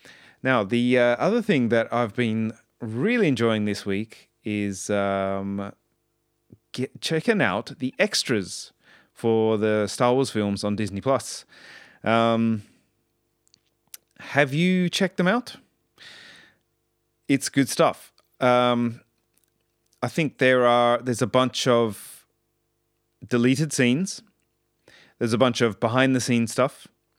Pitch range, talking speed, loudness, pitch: 110-130 Hz, 120 wpm, -23 LUFS, 120 Hz